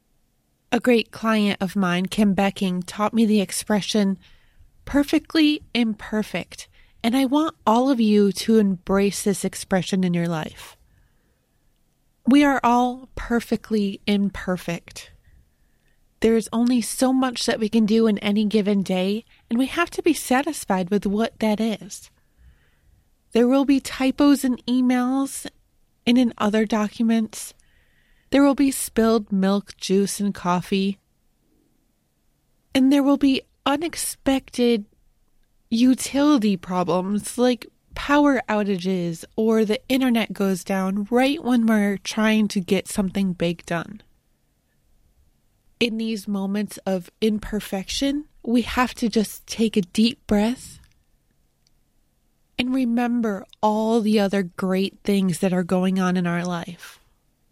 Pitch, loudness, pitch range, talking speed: 220 Hz, -22 LUFS, 195-245 Hz, 130 wpm